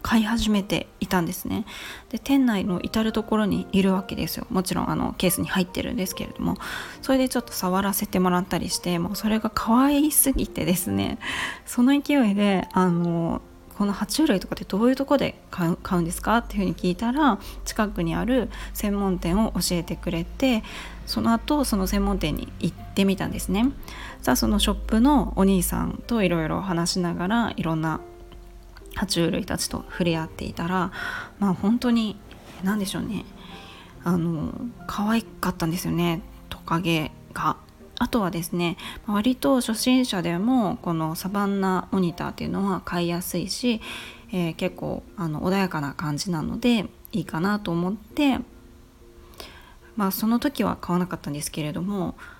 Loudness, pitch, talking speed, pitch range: -25 LUFS, 195 Hz, 340 characters per minute, 175-230 Hz